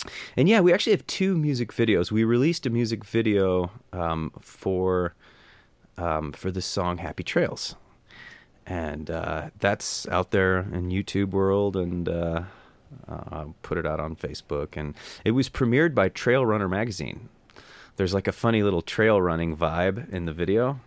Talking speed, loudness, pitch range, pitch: 165 wpm, -25 LUFS, 85-115 Hz, 95 Hz